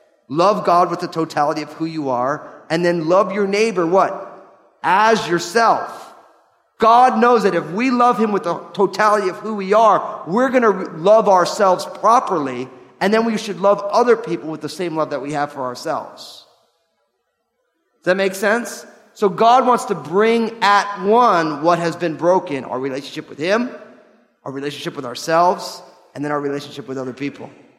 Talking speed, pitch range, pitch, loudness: 175 wpm, 155-215 Hz, 180 Hz, -17 LUFS